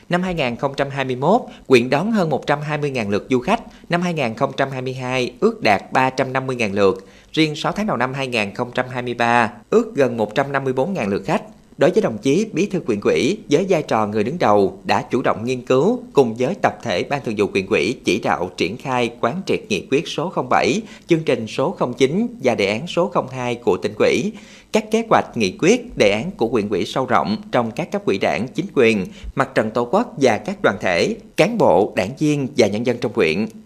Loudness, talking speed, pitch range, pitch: -19 LUFS, 200 wpm, 125-190 Hz, 135 Hz